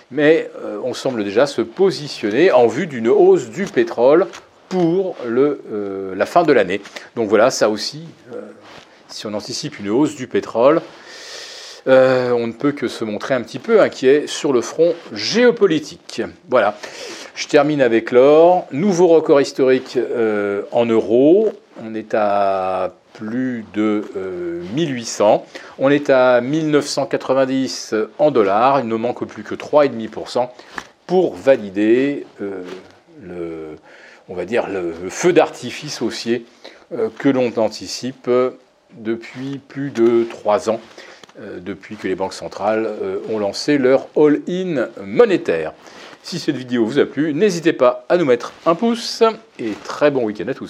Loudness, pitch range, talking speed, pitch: -17 LUFS, 110-165 Hz, 145 wpm, 130 Hz